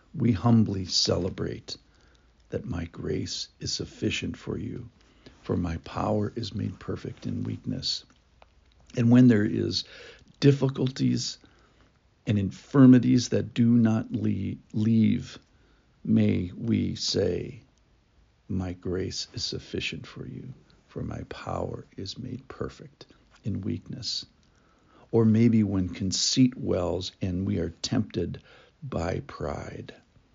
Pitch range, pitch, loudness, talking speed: 90-115 Hz, 105 Hz, -27 LUFS, 115 wpm